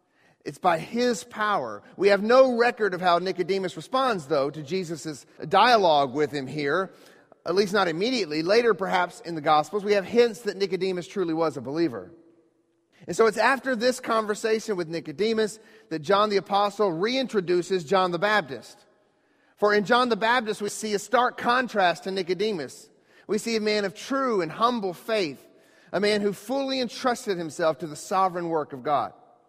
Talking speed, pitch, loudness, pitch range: 175 wpm, 200 Hz, -25 LUFS, 170-225 Hz